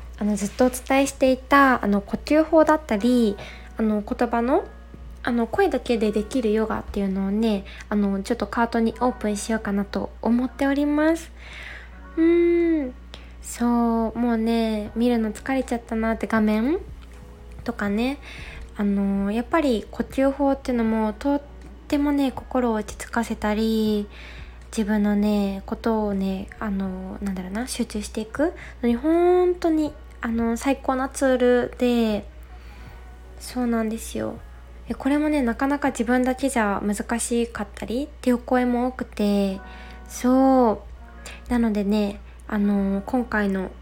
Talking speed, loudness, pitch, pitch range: 285 characters per minute, -23 LUFS, 230 Hz, 210-260 Hz